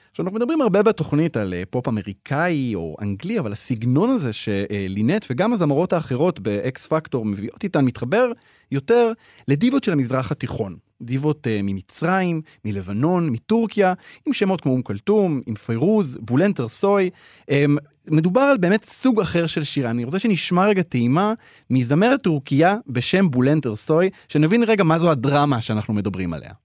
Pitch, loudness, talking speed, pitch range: 145 Hz, -20 LUFS, 145 wpm, 120-190 Hz